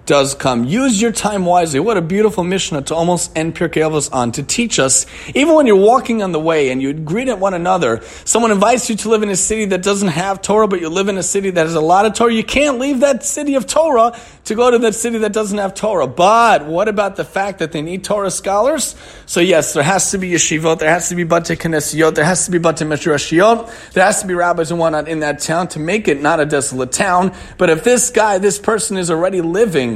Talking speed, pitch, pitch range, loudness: 250 wpm, 185 Hz, 160-215 Hz, -14 LUFS